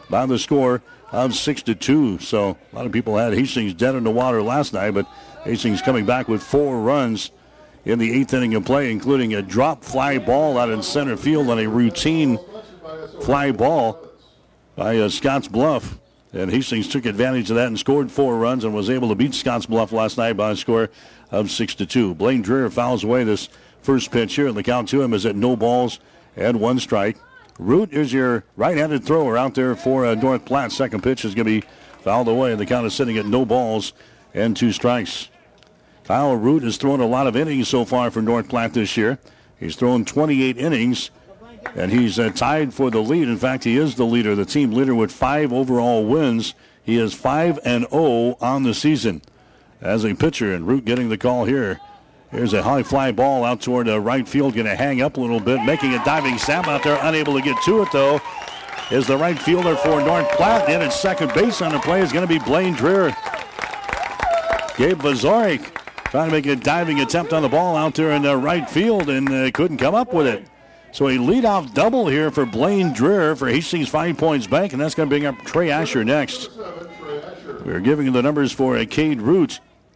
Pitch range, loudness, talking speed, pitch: 115-145 Hz, -19 LUFS, 210 wpm, 130 Hz